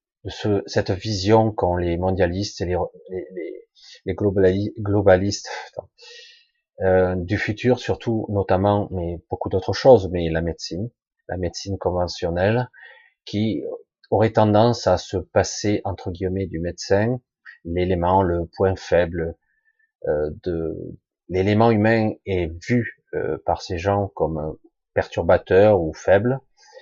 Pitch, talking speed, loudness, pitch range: 100 Hz, 120 wpm, -21 LUFS, 90-120 Hz